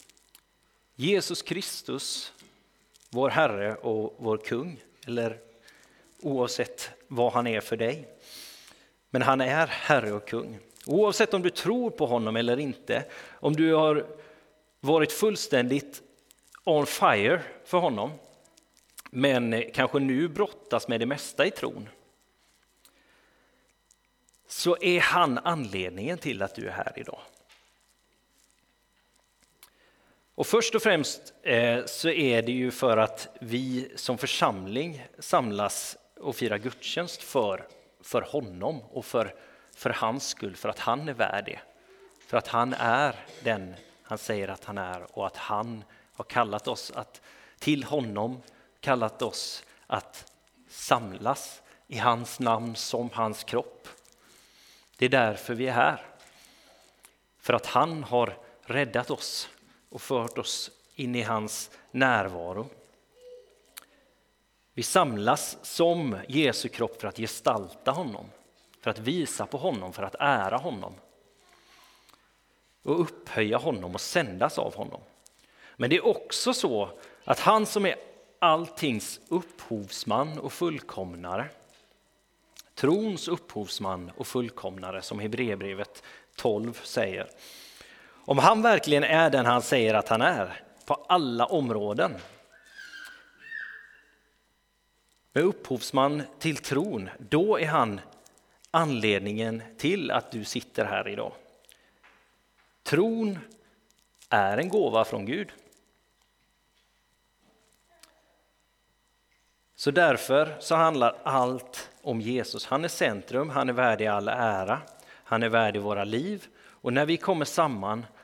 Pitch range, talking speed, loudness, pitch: 115-165 Hz, 120 wpm, -28 LUFS, 125 Hz